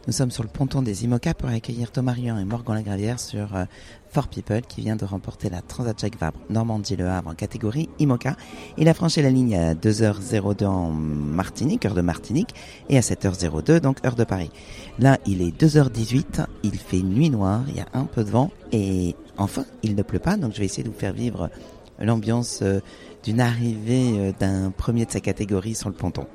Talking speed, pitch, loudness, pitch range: 210 wpm, 110 Hz, -24 LUFS, 95-125 Hz